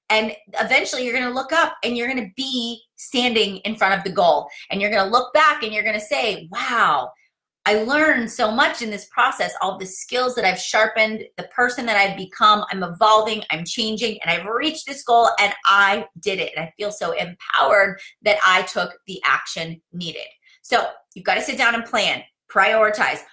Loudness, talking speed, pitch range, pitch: -19 LUFS, 195 wpm, 195-250 Hz, 220 Hz